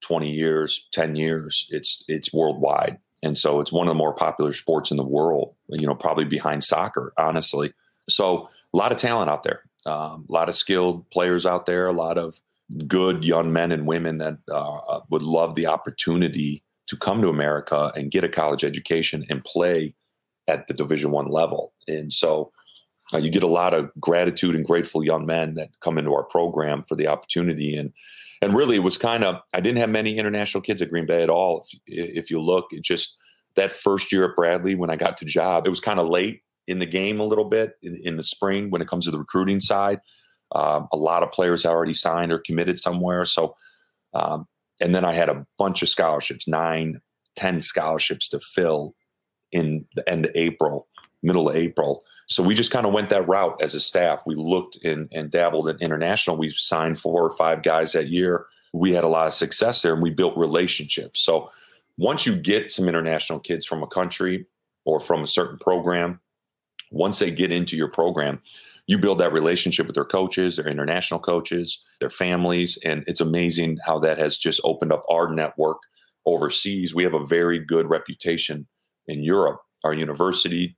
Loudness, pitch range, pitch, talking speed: -22 LUFS, 80-90 Hz, 85 Hz, 200 wpm